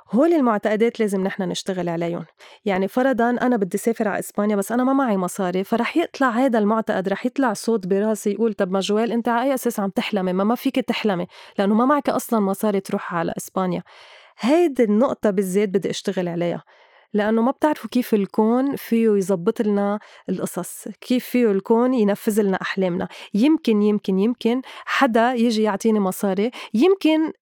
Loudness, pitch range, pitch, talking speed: -21 LUFS, 200-240 Hz, 220 Hz, 170 wpm